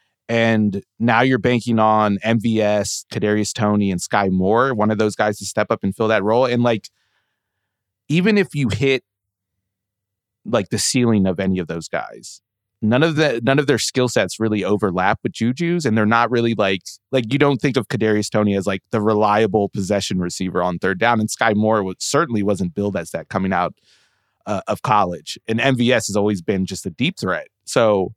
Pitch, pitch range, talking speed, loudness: 105 Hz, 100-115 Hz, 195 wpm, -19 LUFS